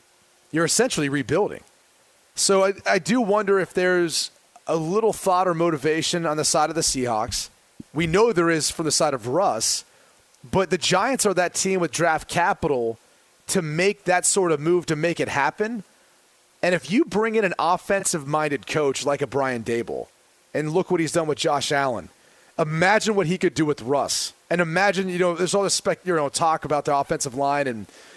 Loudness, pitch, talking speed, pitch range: -22 LUFS, 170 Hz, 190 wpm, 150-190 Hz